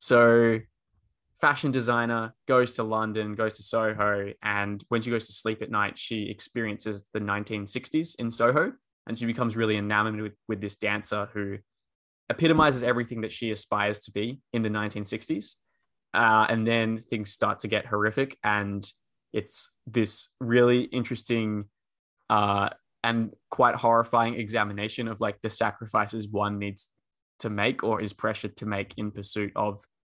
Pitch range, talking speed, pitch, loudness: 105-115 Hz, 155 wpm, 110 Hz, -27 LUFS